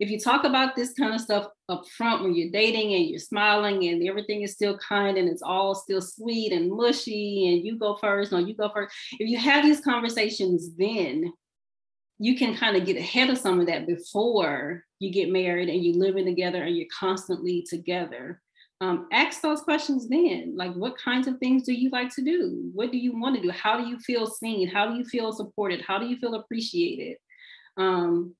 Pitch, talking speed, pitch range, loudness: 210 Hz, 215 wpm, 180-245 Hz, -25 LUFS